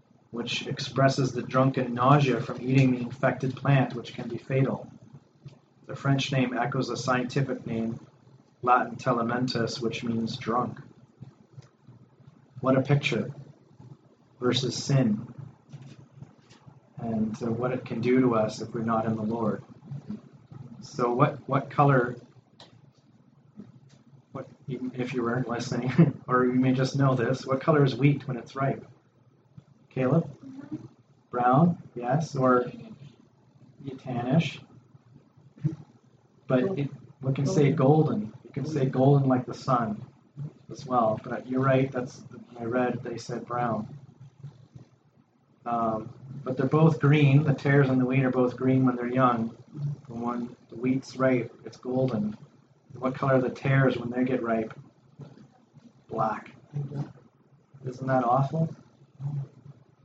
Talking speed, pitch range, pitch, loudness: 135 wpm, 120-140 Hz, 130 Hz, -27 LUFS